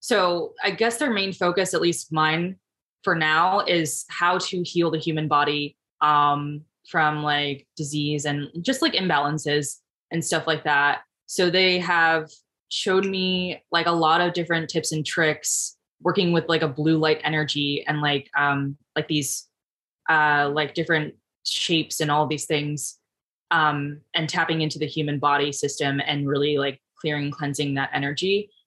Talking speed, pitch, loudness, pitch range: 165 wpm, 155 Hz, -23 LUFS, 145-170 Hz